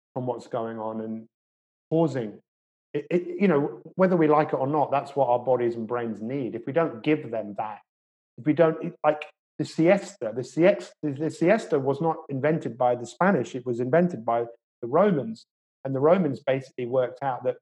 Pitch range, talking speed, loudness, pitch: 115-160 Hz, 200 wpm, -25 LUFS, 135 Hz